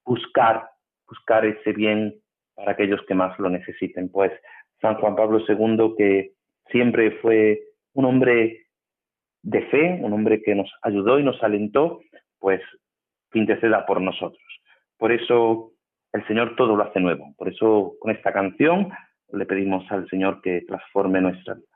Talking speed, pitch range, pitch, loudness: 150 wpm, 95-115 Hz, 105 Hz, -22 LUFS